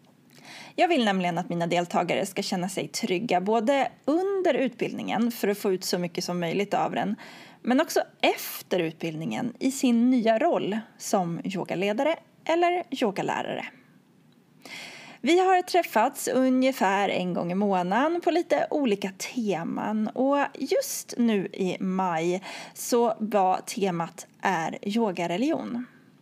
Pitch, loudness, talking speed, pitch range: 220 Hz, -26 LUFS, 130 wpm, 185-260 Hz